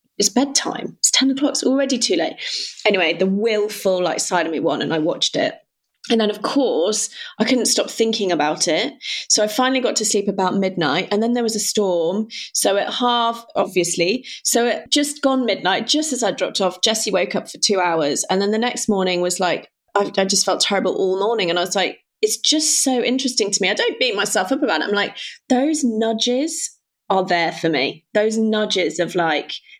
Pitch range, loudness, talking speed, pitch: 190-255 Hz, -19 LUFS, 220 wpm, 215 Hz